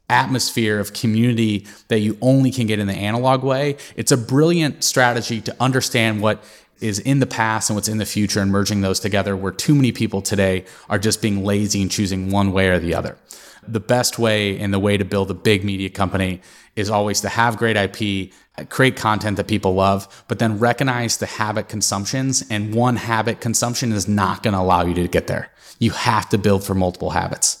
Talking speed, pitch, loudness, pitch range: 210 wpm, 105 Hz, -19 LUFS, 100-115 Hz